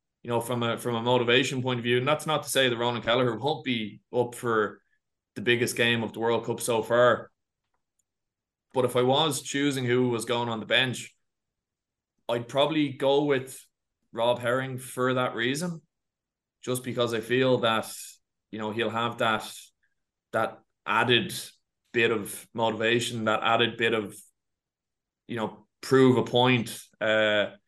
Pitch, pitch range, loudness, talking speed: 120 Hz, 115-125 Hz, -26 LUFS, 165 wpm